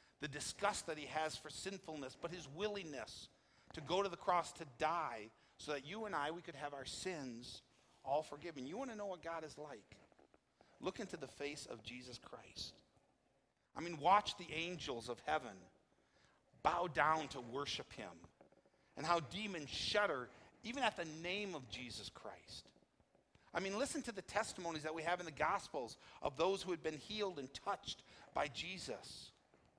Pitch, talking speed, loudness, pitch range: 160 Hz, 180 wpm, -43 LUFS, 145-185 Hz